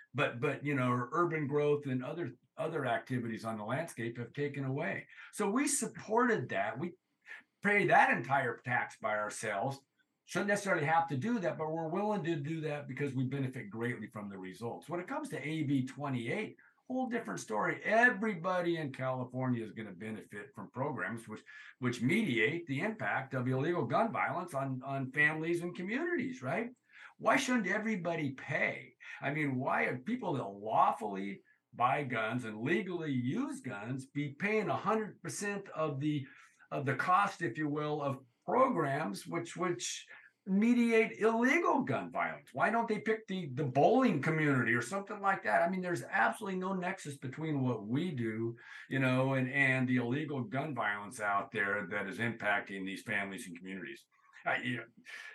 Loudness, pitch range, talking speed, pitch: -34 LUFS, 125-190 Hz, 165 wpm, 145 Hz